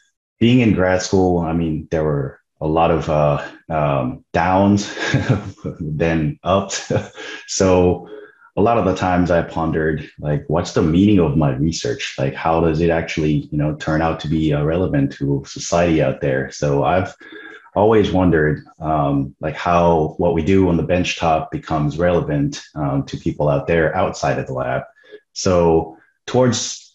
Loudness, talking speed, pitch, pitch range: -18 LUFS, 165 wpm, 85 Hz, 75-95 Hz